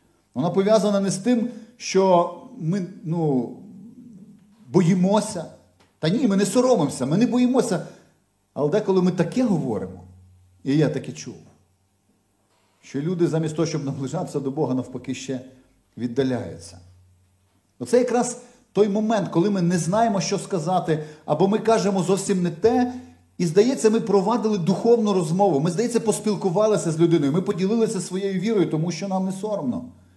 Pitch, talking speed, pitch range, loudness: 185 Hz, 145 wpm, 135-215 Hz, -22 LUFS